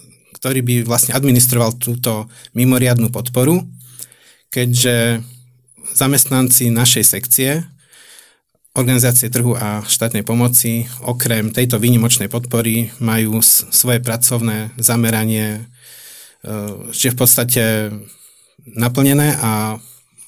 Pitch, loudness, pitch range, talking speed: 120 Hz, -14 LUFS, 115-125 Hz, 85 wpm